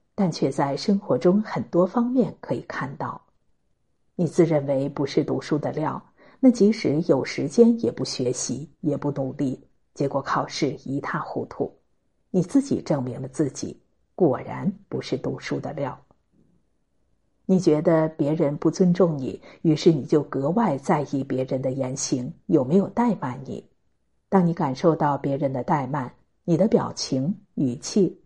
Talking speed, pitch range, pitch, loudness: 225 characters per minute, 135-190 Hz, 155 Hz, -24 LUFS